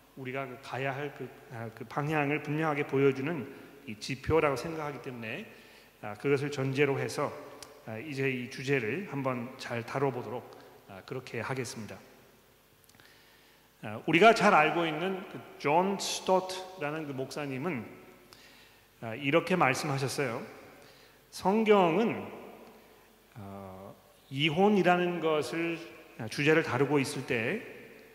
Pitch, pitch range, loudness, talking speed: 145 Hz, 130-160 Hz, -30 LUFS, 230 characters per minute